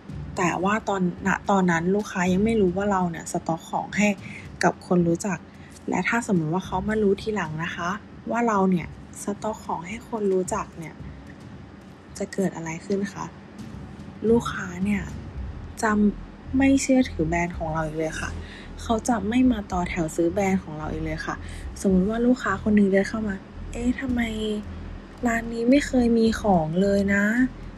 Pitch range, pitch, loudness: 175-220 Hz, 200 Hz, -24 LUFS